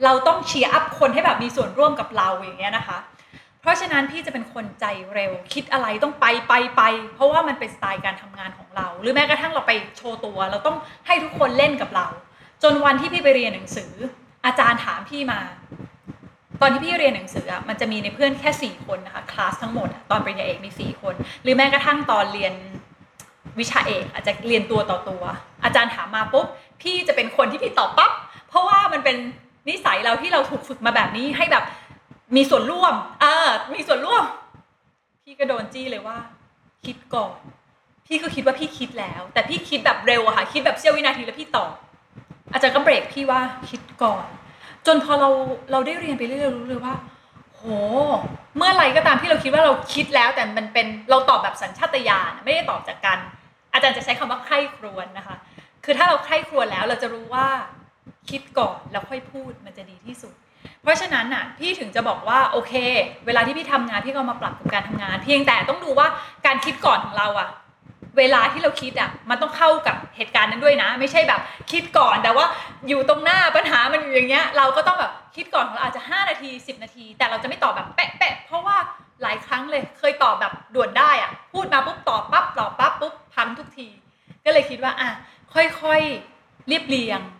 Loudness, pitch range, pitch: -20 LUFS, 235-300 Hz, 270 Hz